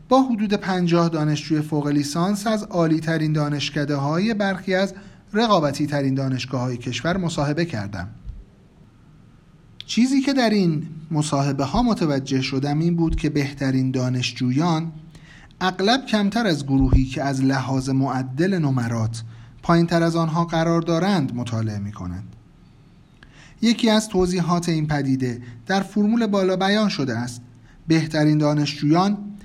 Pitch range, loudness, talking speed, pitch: 135-185 Hz, -21 LUFS, 130 wpm, 155 Hz